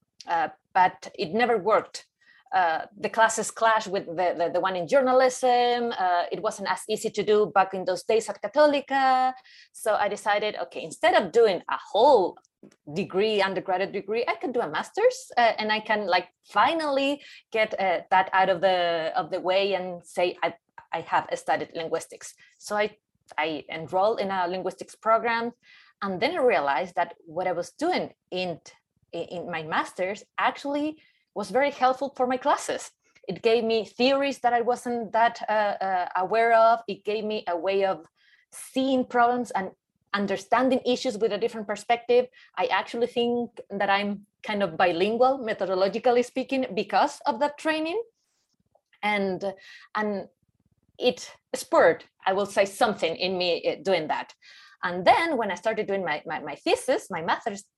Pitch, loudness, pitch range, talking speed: 215 Hz, -25 LUFS, 190-250 Hz, 165 wpm